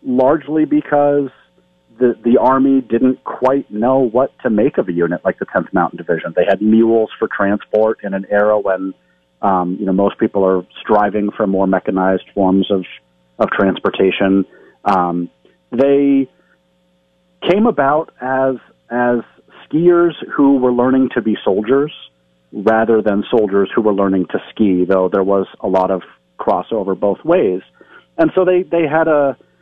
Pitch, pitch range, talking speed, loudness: 105 Hz, 95-130 Hz, 160 wpm, -15 LUFS